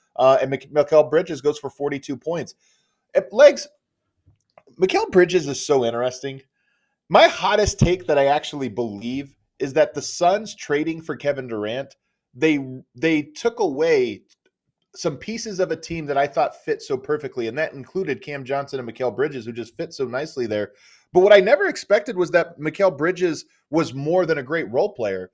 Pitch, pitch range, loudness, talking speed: 150 Hz, 135-185 Hz, -21 LUFS, 180 wpm